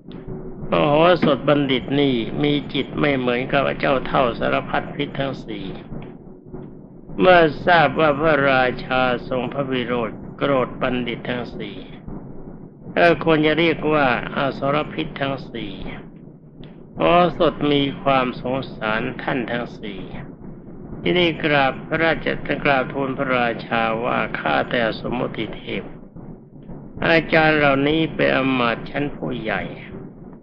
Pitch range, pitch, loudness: 130-160 Hz, 145 Hz, -20 LUFS